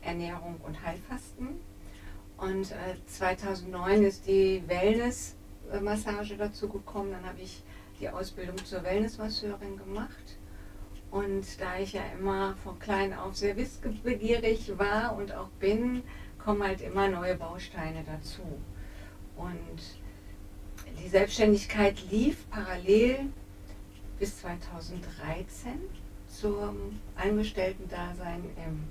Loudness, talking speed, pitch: -32 LUFS, 100 wpm, 190 Hz